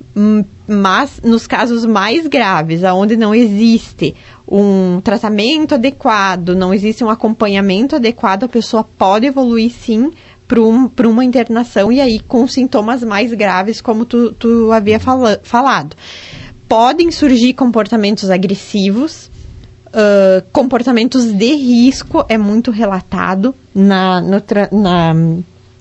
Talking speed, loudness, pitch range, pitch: 120 wpm, -11 LUFS, 200-245 Hz, 225 Hz